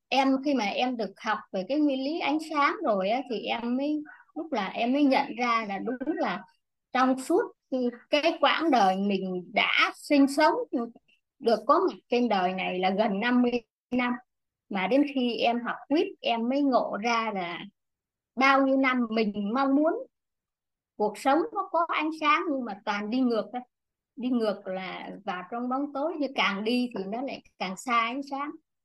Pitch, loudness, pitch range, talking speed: 255 Hz, -27 LUFS, 220-285 Hz, 190 wpm